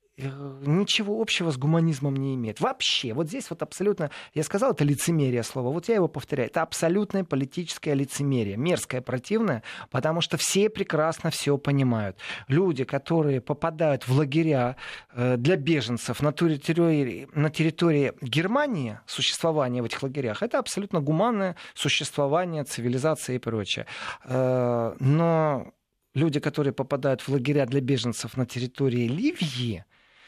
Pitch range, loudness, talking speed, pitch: 130-165 Hz, -26 LUFS, 130 wpm, 145 Hz